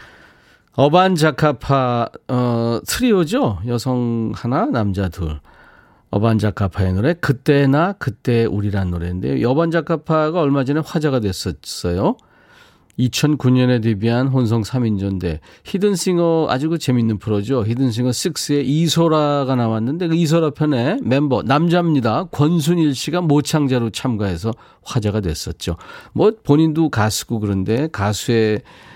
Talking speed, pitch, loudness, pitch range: 285 characters per minute, 130 Hz, -18 LUFS, 110-155 Hz